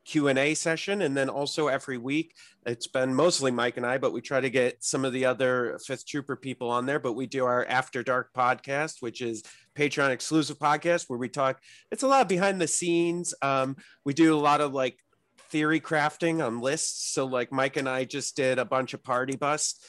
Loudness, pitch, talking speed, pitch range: -27 LUFS, 135 Hz, 225 wpm, 130-150 Hz